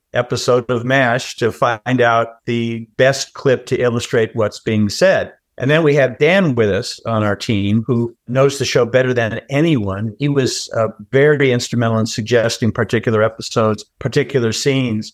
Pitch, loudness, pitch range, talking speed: 120 Hz, -16 LUFS, 115-130 Hz, 165 wpm